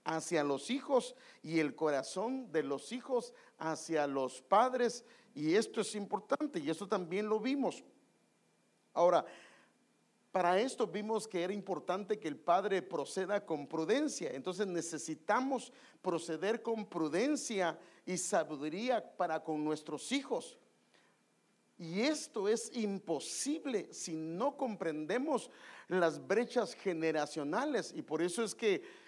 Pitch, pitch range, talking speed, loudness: 195 Hz, 160-240 Hz, 125 wpm, -36 LUFS